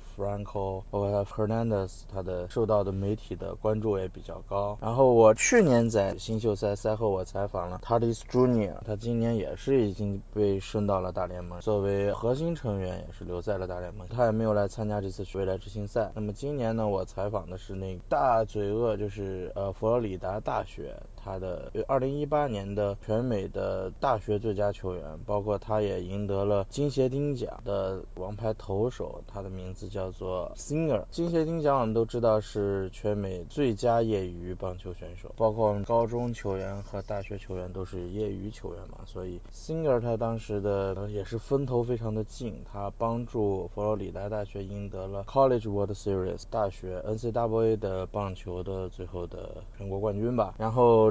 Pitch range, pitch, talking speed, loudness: 95-110 Hz, 105 Hz, 325 characters per minute, -30 LUFS